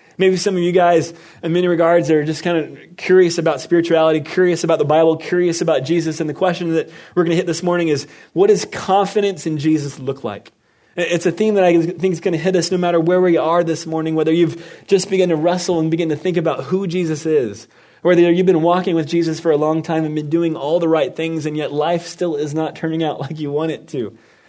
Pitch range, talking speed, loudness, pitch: 160-180 Hz, 250 wpm, -17 LUFS, 170 Hz